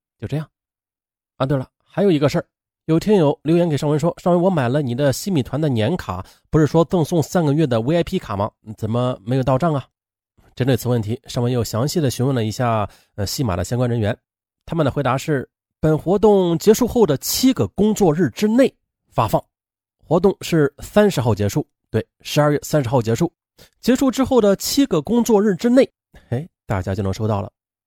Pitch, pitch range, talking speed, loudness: 145 Hz, 115-175 Hz, 300 characters per minute, -19 LUFS